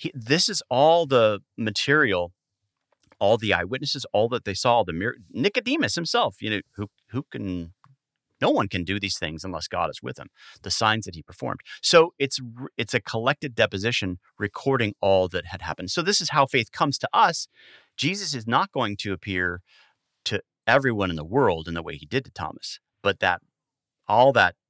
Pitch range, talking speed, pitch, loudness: 95-140 Hz, 190 wpm, 115 Hz, -24 LUFS